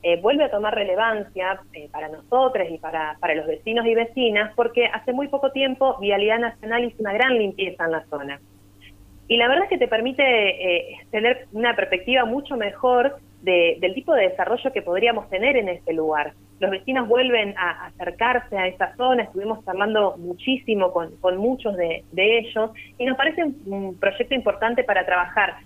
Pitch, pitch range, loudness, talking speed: 215 Hz, 180-245 Hz, -22 LUFS, 185 wpm